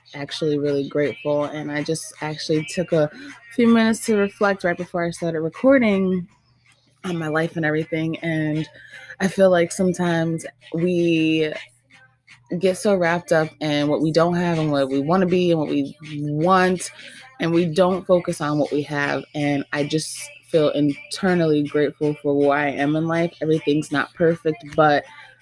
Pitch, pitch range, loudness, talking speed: 155 Hz, 145-175 Hz, -21 LUFS, 170 wpm